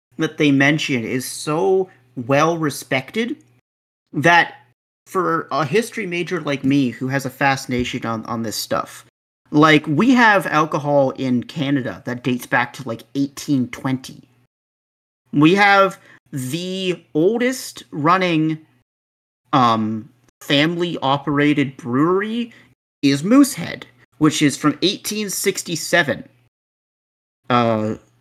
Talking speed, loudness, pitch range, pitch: 100 wpm, -18 LUFS, 130-175 Hz, 145 Hz